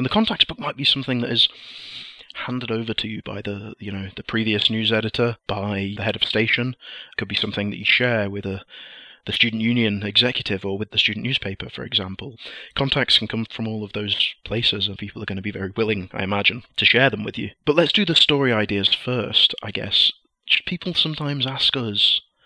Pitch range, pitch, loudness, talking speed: 100-125 Hz, 110 Hz, -20 LUFS, 220 wpm